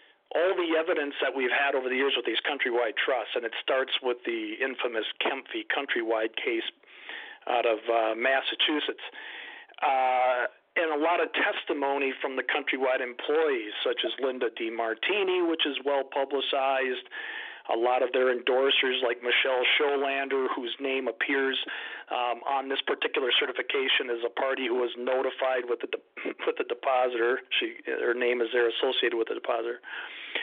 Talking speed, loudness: 160 wpm, -28 LUFS